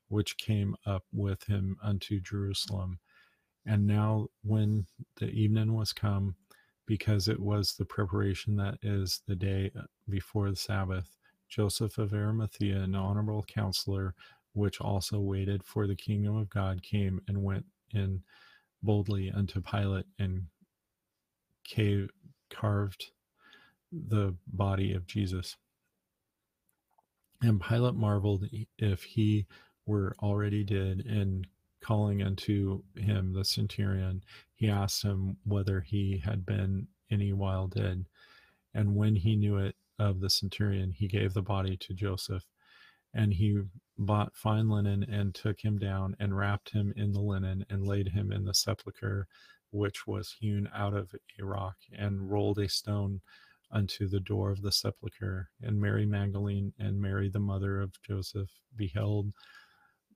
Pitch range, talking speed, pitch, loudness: 95-105 Hz, 140 wpm, 100 Hz, -32 LUFS